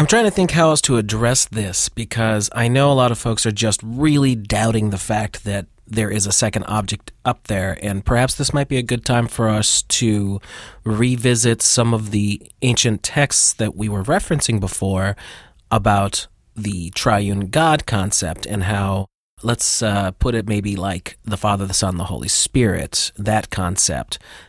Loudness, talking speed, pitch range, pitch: -18 LUFS, 180 wpm, 100-120 Hz, 110 Hz